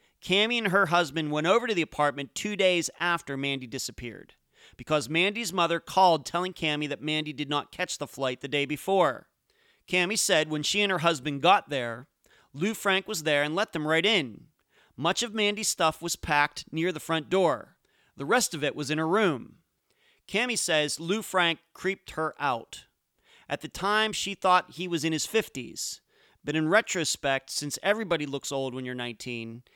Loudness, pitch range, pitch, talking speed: -27 LUFS, 145-190 Hz, 165 Hz, 190 wpm